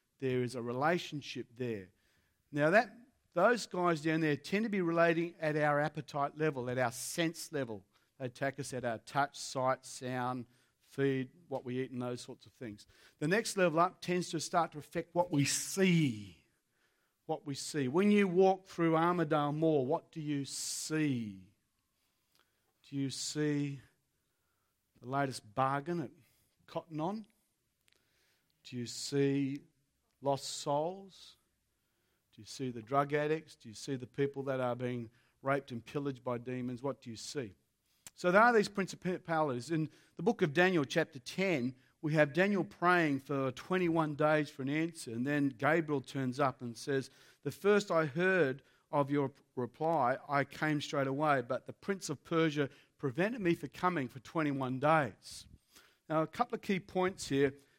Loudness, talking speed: -34 LUFS, 165 wpm